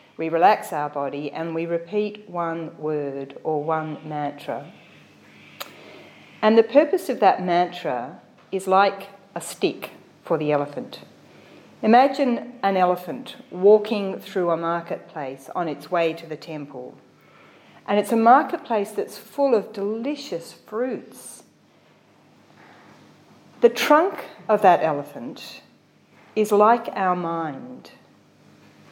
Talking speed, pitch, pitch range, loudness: 115 wpm, 180 Hz, 155-215 Hz, -22 LUFS